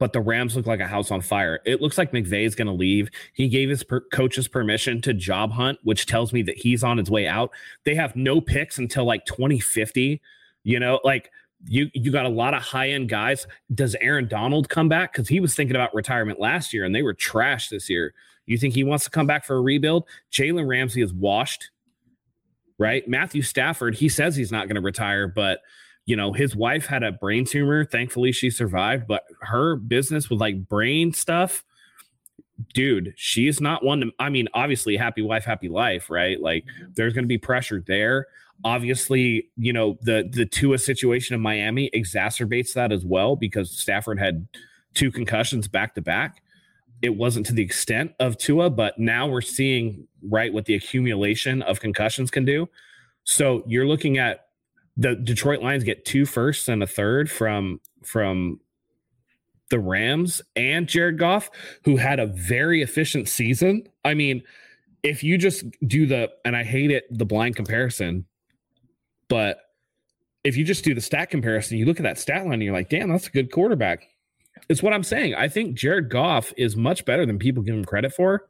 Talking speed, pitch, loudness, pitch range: 195 wpm, 125 Hz, -23 LUFS, 110-140 Hz